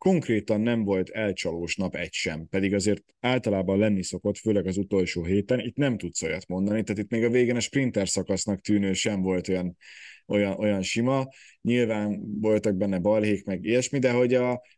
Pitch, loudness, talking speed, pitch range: 105 Hz, -26 LUFS, 185 wpm, 95-120 Hz